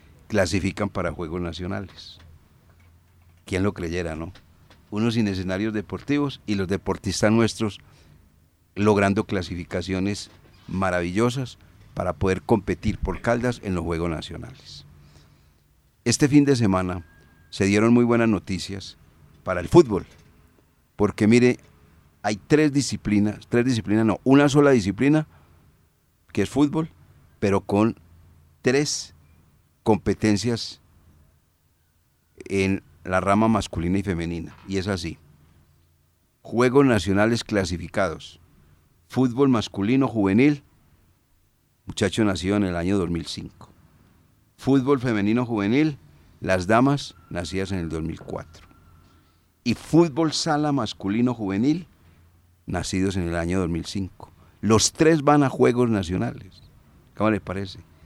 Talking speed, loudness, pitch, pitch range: 110 wpm, -23 LUFS, 95 Hz, 85-110 Hz